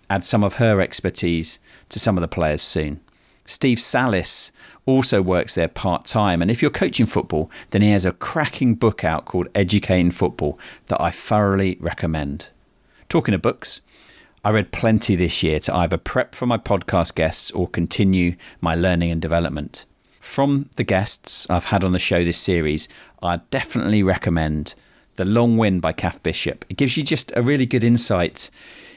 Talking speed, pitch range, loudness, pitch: 175 wpm, 85-105 Hz, -20 LUFS, 95 Hz